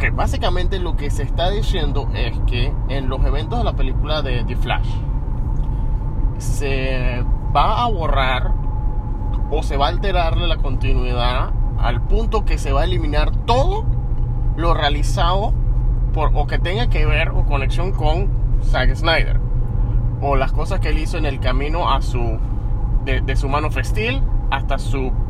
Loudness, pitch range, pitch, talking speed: -21 LUFS, 115-130 Hz, 120 Hz, 160 wpm